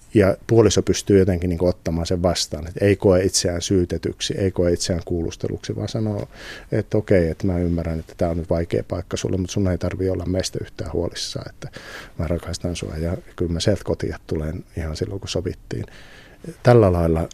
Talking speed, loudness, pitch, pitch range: 190 wpm, -22 LUFS, 90 Hz, 85-100 Hz